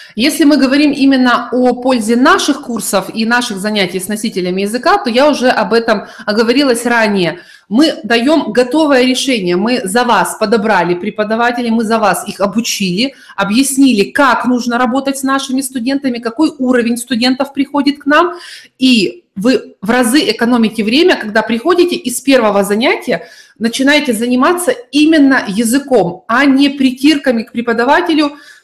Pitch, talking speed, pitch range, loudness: 245 Hz, 140 wpm, 225-275 Hz, -12 LUFS